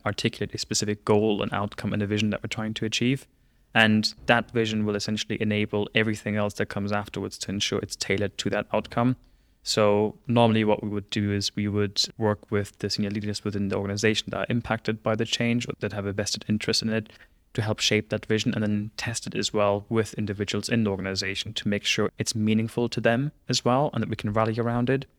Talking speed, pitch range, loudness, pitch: 225 wpm, 105-115 Hz, -26 LUFS, 105 Hz